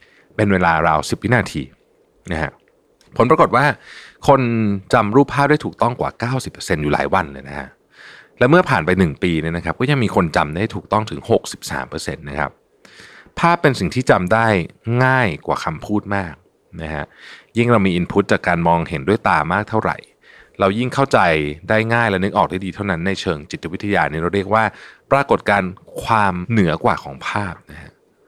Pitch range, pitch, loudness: 85-115 Hz, 100 Hz, -18 LUFS